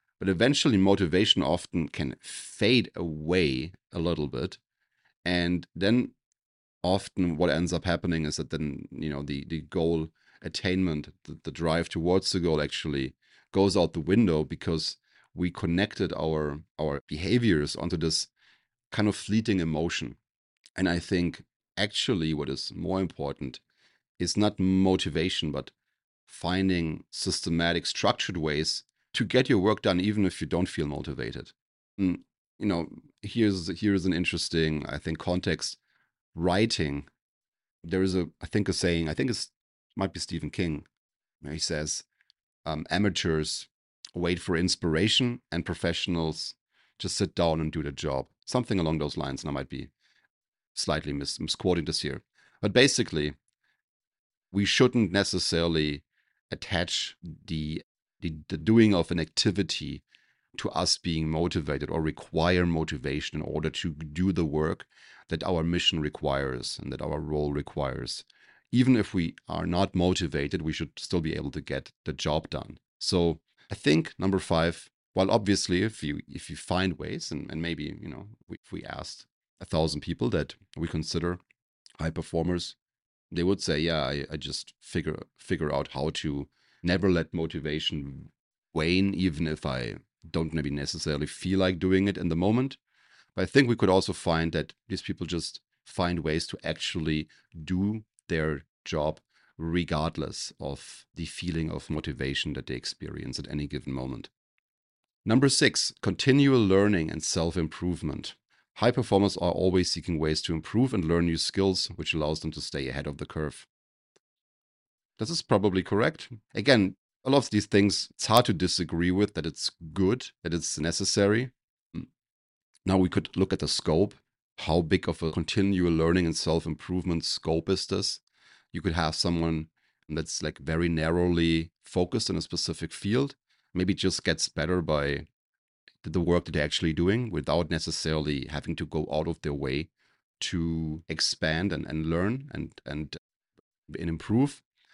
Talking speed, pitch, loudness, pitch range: 155 wpm, 85 Hz, -28 LUFS, 80-95 Hz